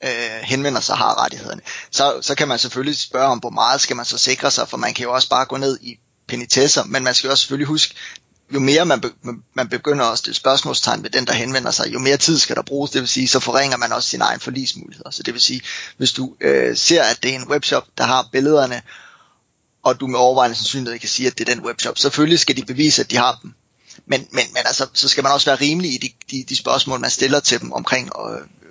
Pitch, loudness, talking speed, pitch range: 130 Hz, -17 LUFS, 255 wpm, 125-140 Hz